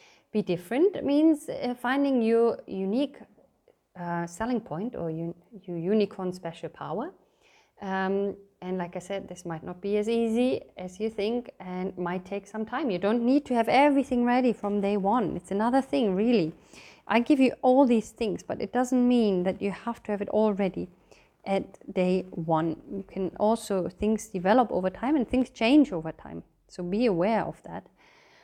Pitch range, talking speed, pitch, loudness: 185-245 Hz, 185 wpm, 210 Hz, -27 LUFS